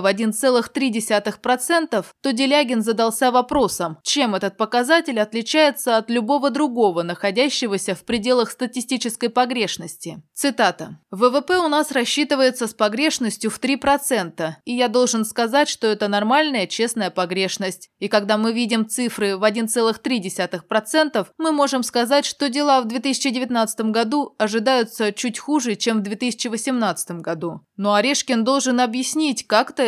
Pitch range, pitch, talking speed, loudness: 215-265 Hz, 235 Hz, 125 wpm, -20 LUFS